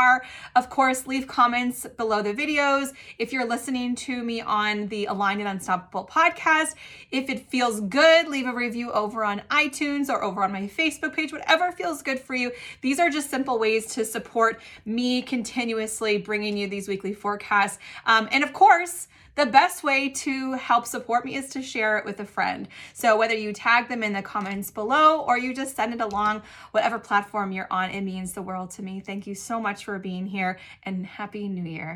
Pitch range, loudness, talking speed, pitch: 205-265 Hz, -24 LUFS, 200 wpm, 230 Hz